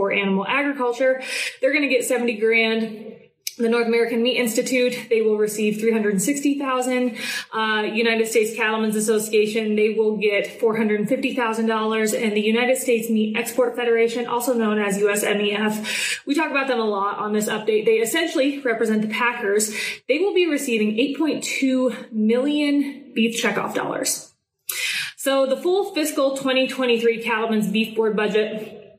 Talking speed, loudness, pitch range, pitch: 170 wpm, -21 LUFS, 215-260 Hz, 230 Hz